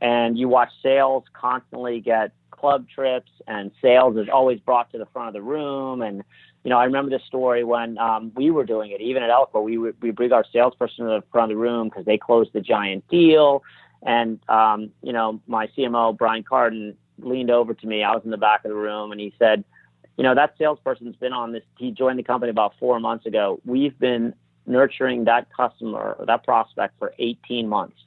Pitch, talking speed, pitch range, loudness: 120 Hz, 215 wpm, 110-125 Hz, -21 LUFS